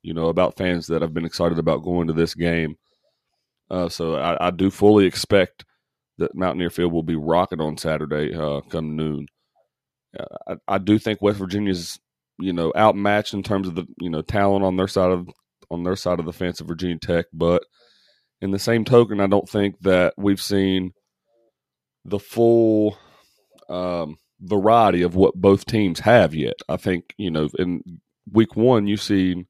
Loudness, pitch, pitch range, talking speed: -21 LUFS, 90 Hz, 85-100 Hz, 185 wpm